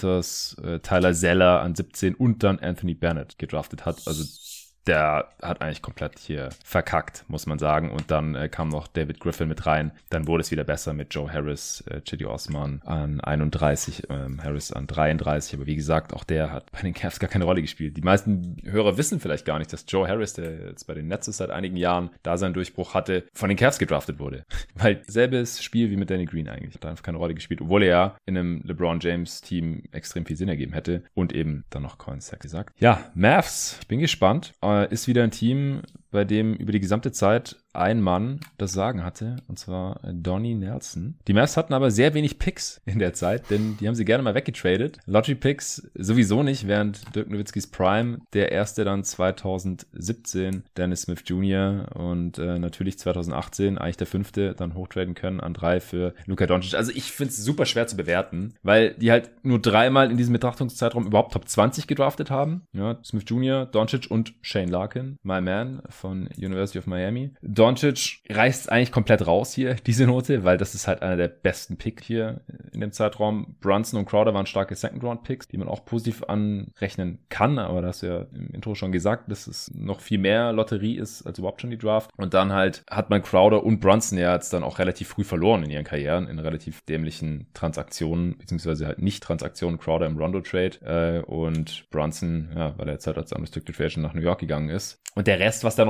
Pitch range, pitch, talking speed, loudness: 85-110 Hz, 95 Hz, 200 wpm, -25 LUFS